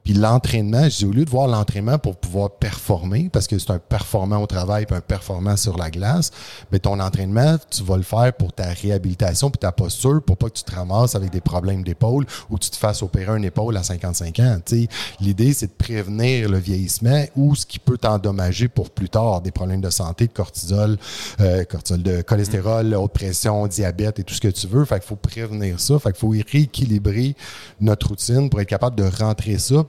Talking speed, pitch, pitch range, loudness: 220 wpm, 105 Hz, 95-120 Hz, -20 LUFS